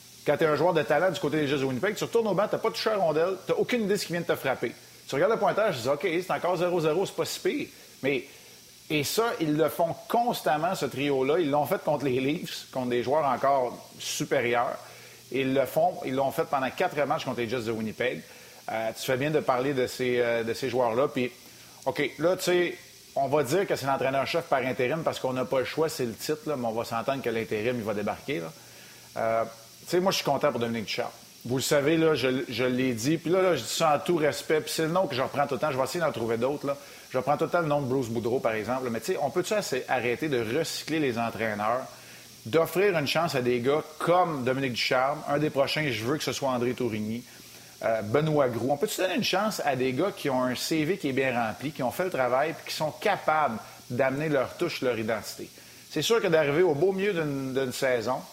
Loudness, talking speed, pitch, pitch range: -27 LUFS, 260 wpm, 140 Hz, 125-160 Hz